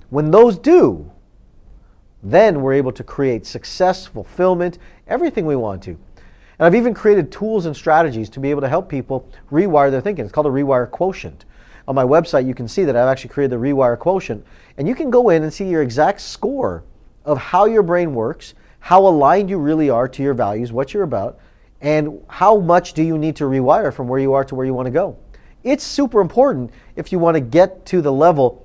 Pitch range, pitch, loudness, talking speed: 130-185 Hz, 150 Hz, -16 LUFS, 215 wpm